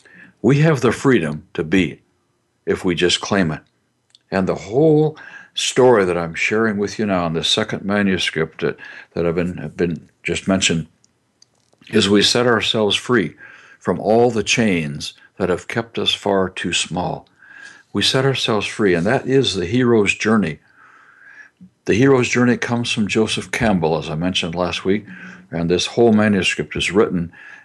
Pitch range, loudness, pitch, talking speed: 90-120 Hz, -18 LUFS, 100 Hz, 165 wpm